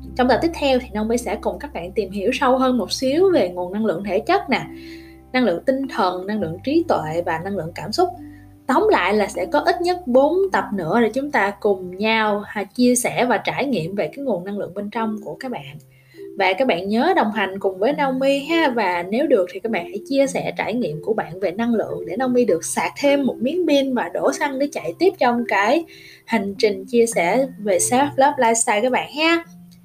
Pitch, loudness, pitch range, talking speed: 235 Hz, -20 LUFS, 200-275 Hz, 240 wpm